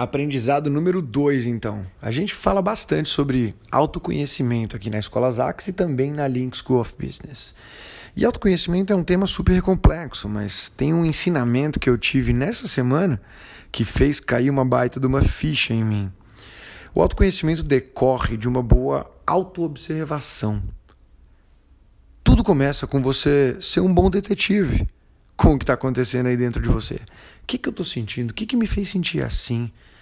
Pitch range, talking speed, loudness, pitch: 120-165 Hz, 170 wpm, -21 LUFS, 135 Hz